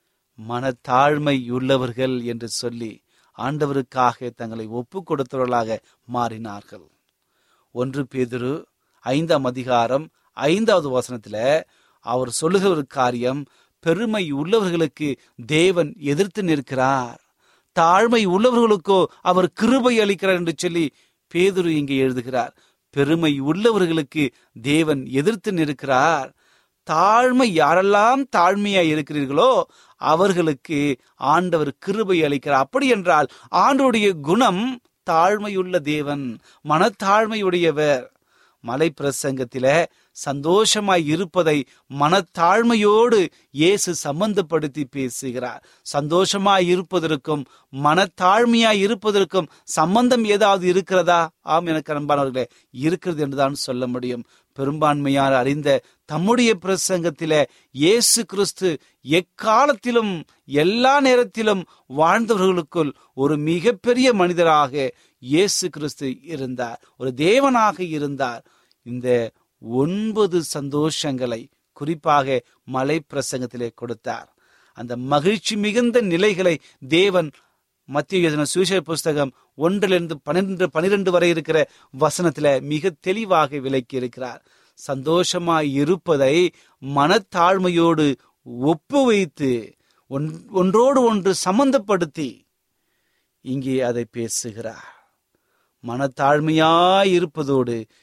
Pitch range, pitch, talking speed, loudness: 135-190 Hz, 155 Hz, 75 wpm, -20 LUFS